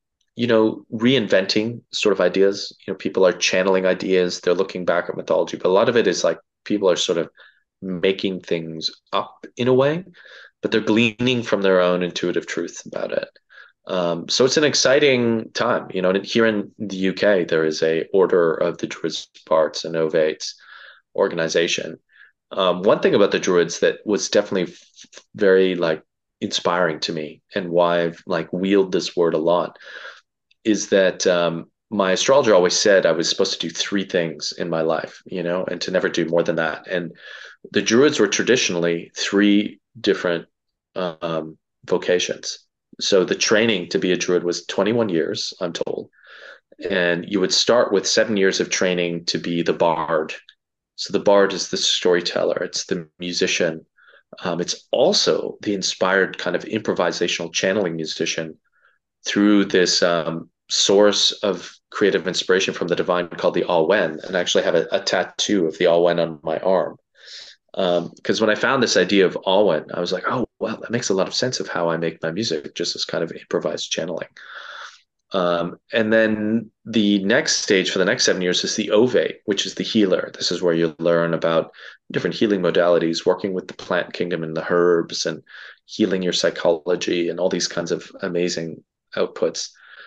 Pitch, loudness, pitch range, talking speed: 90 Hz, -20 LUFS, 85-105 Hz, 185 wpm